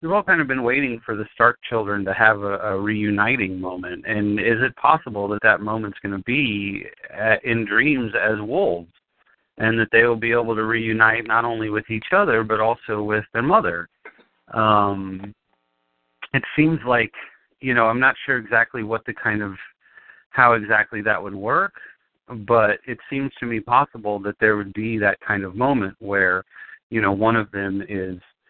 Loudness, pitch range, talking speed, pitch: -20 LUFS, 100-115 Hz, 185 wpm, 110 Hz